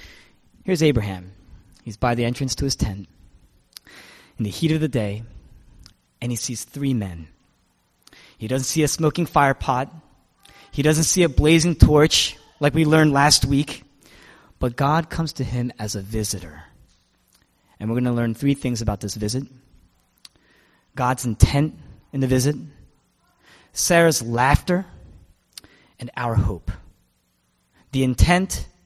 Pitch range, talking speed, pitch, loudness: 95-145 Hz, 140 wpm, 120 Hz, -21 LUFS